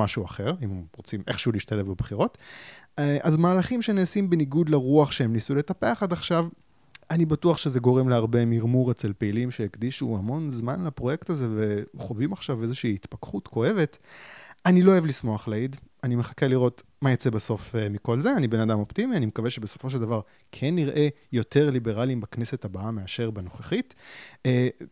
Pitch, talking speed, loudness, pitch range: 125 Hz, 160 wpm, -26 LUFS, 115-150 Hz